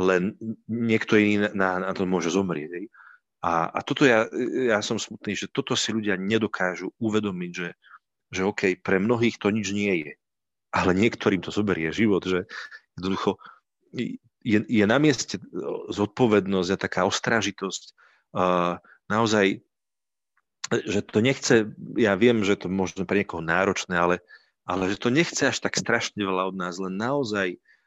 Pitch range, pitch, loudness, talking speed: 95-110 Hz, 100 Hz, -25 LUFS, 150 wpm